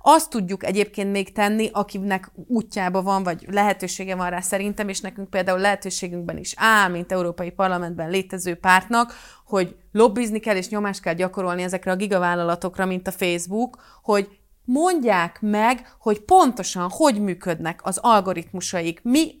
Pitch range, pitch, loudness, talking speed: 185-215 Hz, 195 Hz, -22 LUFS, 145 wpm